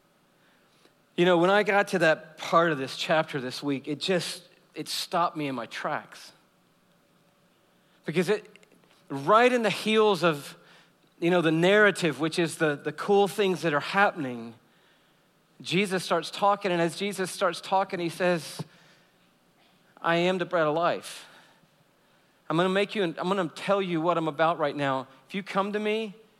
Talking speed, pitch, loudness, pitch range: 175 wpm, 175 Hz, -26 LUFS, 160-195 Hz